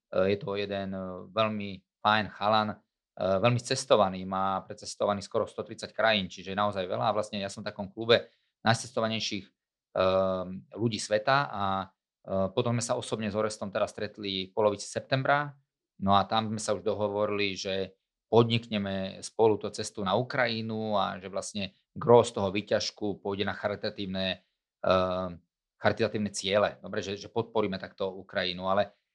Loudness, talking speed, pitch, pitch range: -29 LUFS, 145 wpm, 105 Hz, 95-110 Hz